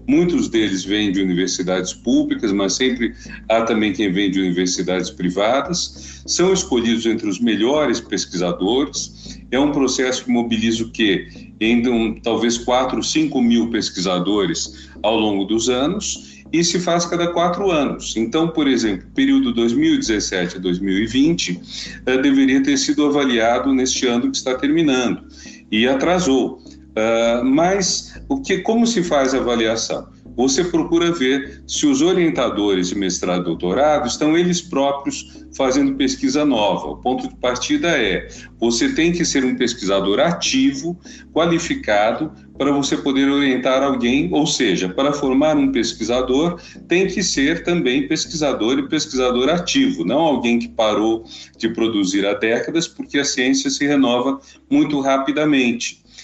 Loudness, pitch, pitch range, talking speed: -18 LUFS, 135 Hz, 115-185 Hz, 140 wpm